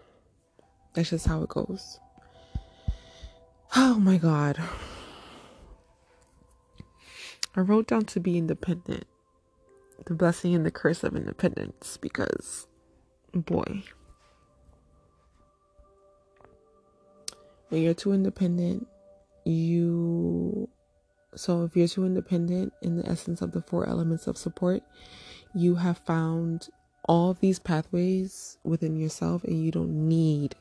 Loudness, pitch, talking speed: -28 LUFS, 165 Hz, 105 wpm